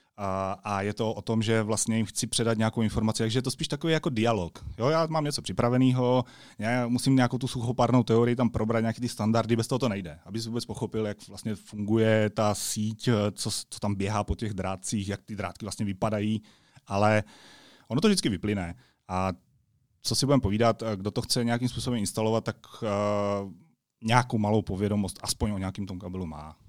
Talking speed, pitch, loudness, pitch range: 195 wpm, 110 Hz, -28 LUFS, 100-120 Hz